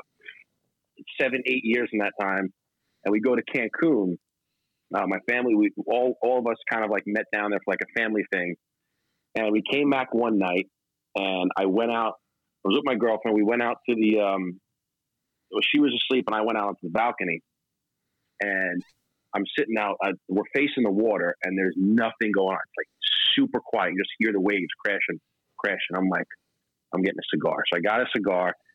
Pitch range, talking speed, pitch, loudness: 100-125 Hz, 205 wpm, 110 Hz, -25 LUFS